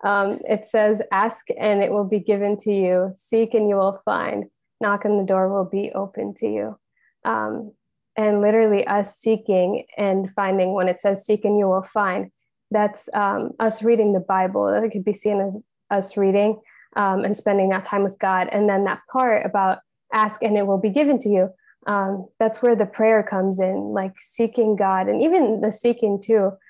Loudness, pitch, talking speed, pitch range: -21 LUFS, 205 Hz, 200 wpm, 195-215 Hz